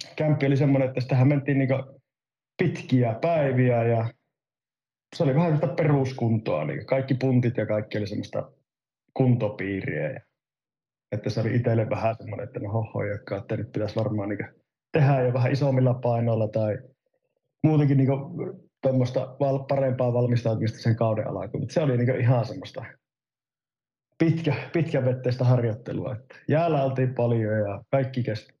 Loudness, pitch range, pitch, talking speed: -25 LUFS, 115-140 Hz, 130 Hz, 135 wpm